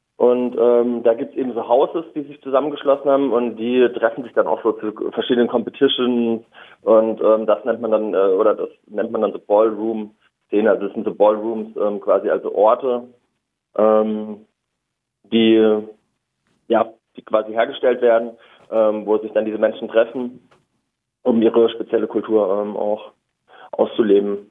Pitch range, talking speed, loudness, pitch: 110-125 Hz, 160 wpm, -18 LUFS, 115 Hz